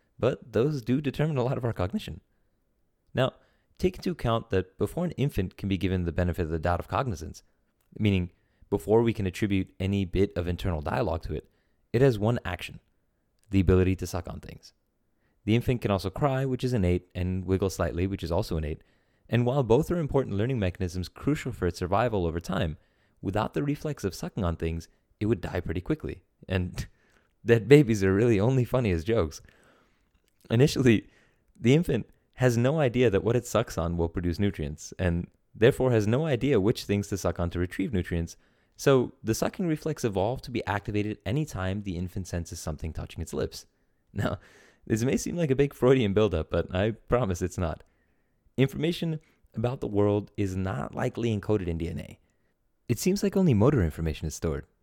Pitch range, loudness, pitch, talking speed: 90-120 Hz, -28 LUFS, 100 Hz, 190 wpm